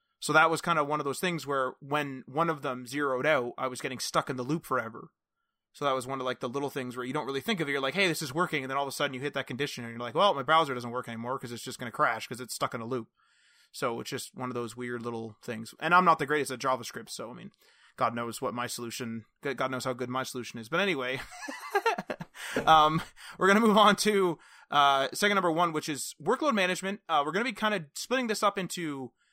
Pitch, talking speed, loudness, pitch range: 140 Hz, 280 wpm, -29 LUFS, 125-165 Hz